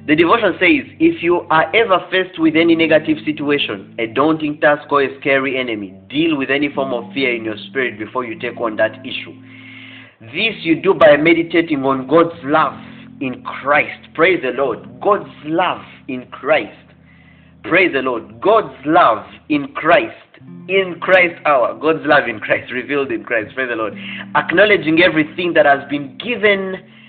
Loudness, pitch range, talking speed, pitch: -16 LUFS, 130-175 Hz, 170 wpm, 150 Hz